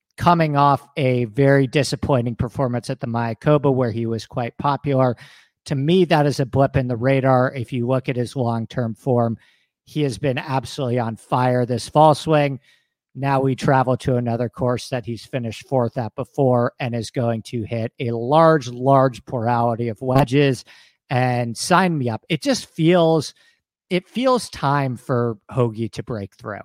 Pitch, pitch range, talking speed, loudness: 130 Hz, 120-140 Hz, 175 wpm, -20 LUFS